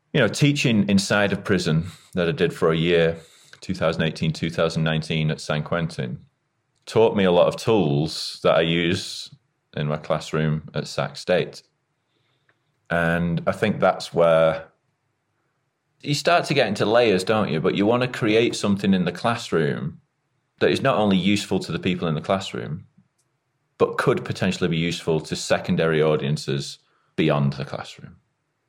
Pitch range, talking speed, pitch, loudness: 80-120 Hz, 160 wpm, 90 Hz, -22 LUFS